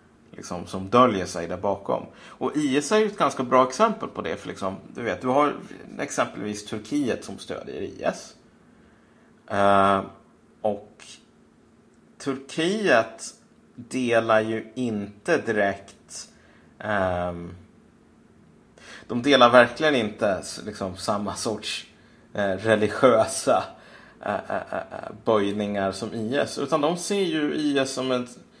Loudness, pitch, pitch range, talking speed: -24 LUFS, 115 Hz, 100-140 Hz, 120 wpm